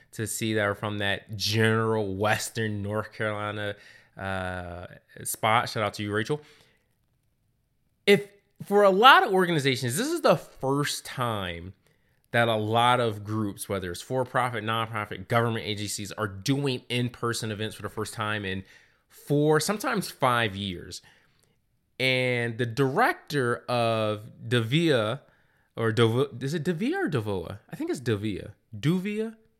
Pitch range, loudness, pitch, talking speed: 105-135 Hz, -26 LUFS, 115 Hz, 140 wpm